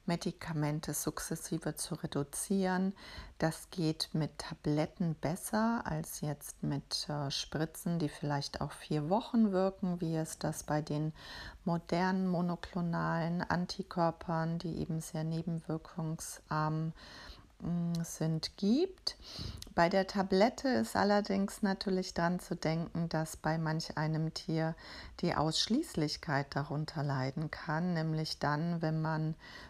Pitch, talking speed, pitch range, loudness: 165 Hz, 115 wpm, 155-180 Hz, -35 LUFS